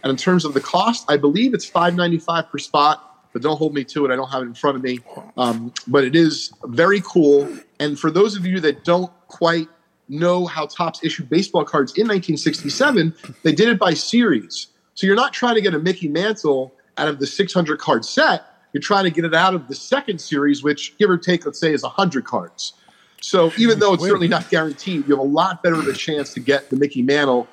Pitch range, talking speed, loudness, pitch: 145-185 Hz, 240 wpm, -18 LUFS, 160 Hz